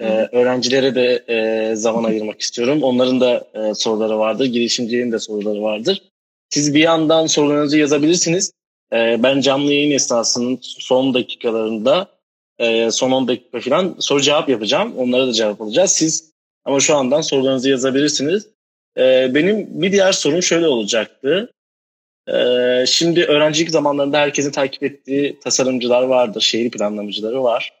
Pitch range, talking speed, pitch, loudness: 115-150 Hz, 140 wpm, 130 Hz, -16 LUFS